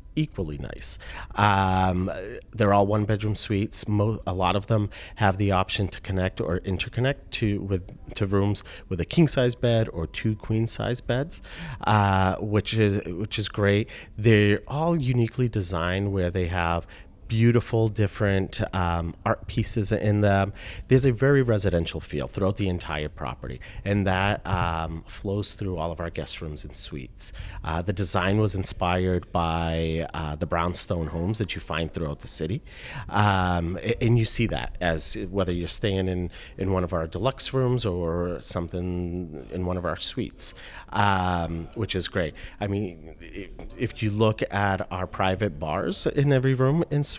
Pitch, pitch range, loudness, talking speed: 95 Hz, 85-110 Hz, -25 LUFS, 165 wpm